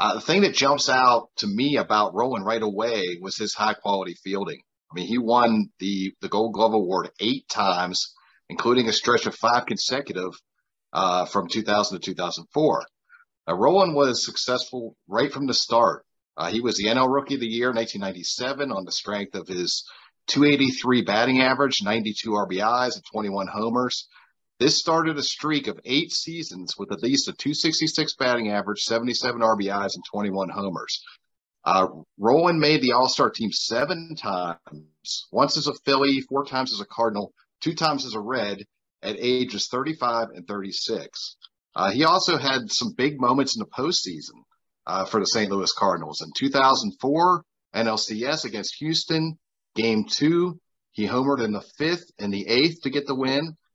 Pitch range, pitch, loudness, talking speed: 105-145 Hz, 125 Hz, -23 LUFS, 170 wpm